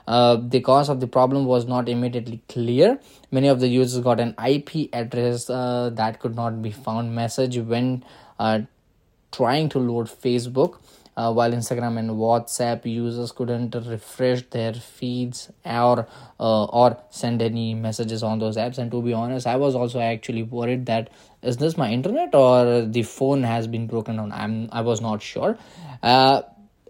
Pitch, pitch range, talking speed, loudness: 120 Hz, 115-125 Hz, 170 wpm, -22 LUFS